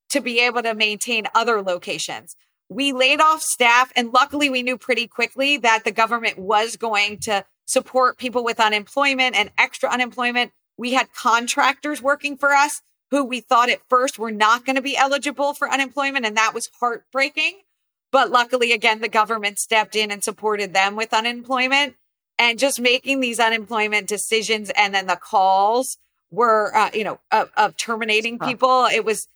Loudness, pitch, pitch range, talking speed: -19 LUFS, 240 Hz, 220-265 Hz, 175 wpm